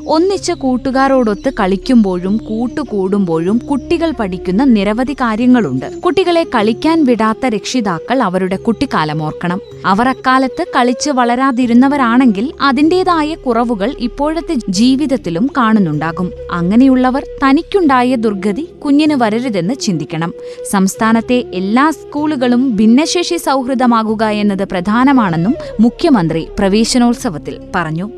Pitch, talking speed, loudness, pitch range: 245 Hz, 85 wpm, -13 LUFS, 205-275 Hz